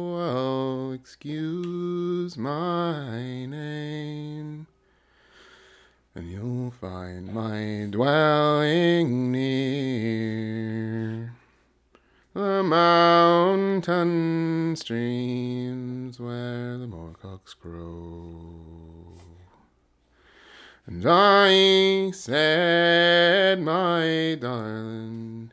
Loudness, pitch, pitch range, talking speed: -23 LUFS, 130 Hz, 110-170 Hz, 50 wpm